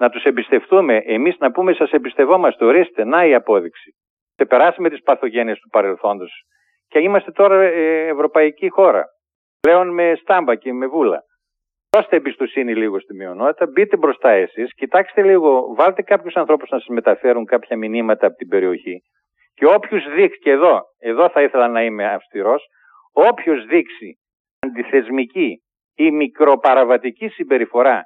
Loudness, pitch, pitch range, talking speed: -16 LUFS, 165 Hz, 130-200 Hz, 150 wpm